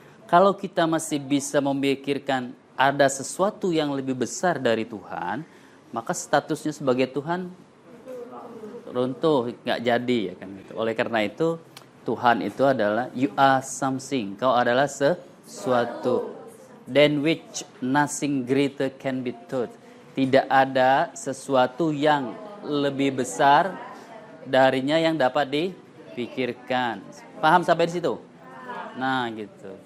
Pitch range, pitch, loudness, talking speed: 130-155 Hz, 135 Hz, -24 LUFS, 115 wpm